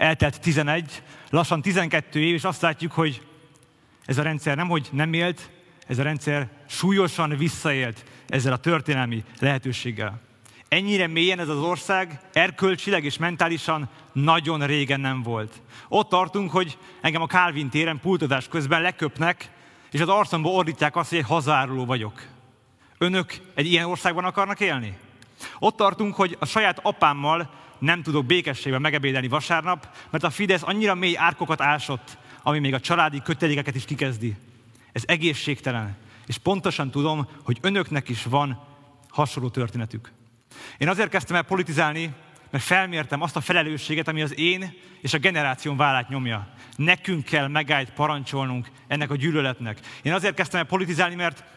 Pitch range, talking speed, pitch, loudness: 135-175 Hz, 150 wpm, 155 Hz, -23 LUFS